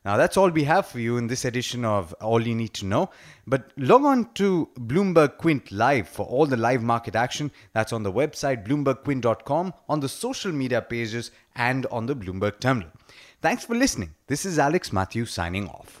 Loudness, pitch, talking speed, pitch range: -24 LUFS, 125 Hz, 200 wpm, 115-150 Hz